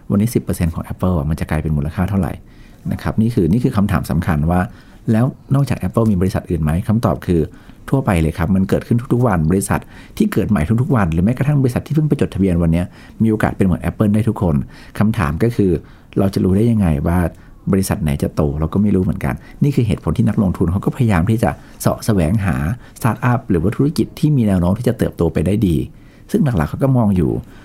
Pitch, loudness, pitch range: 100 Hz, -17 LUFS, 85-115 Hz